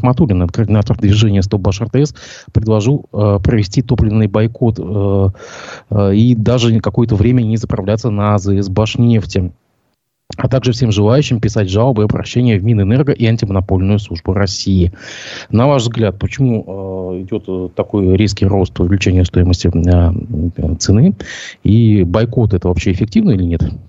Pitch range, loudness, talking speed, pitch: 95-120 Hz, -14 LUFS, 140 wpm, 105 Hz